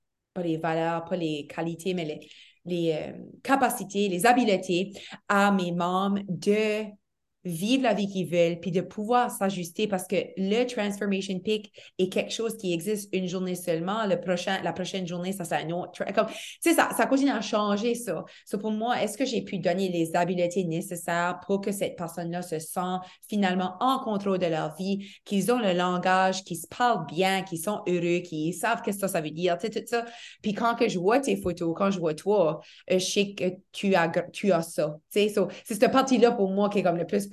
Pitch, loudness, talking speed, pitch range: 190 Hz, -27 LUFS, 210 wpm, 175-210 Hz